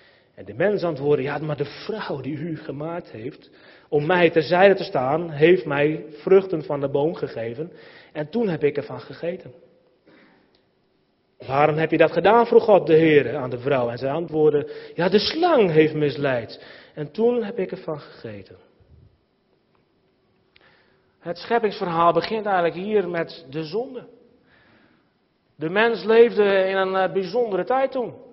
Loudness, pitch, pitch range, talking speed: -21 LUFS, 170 Hz, 150-200 Hz, 150 wpm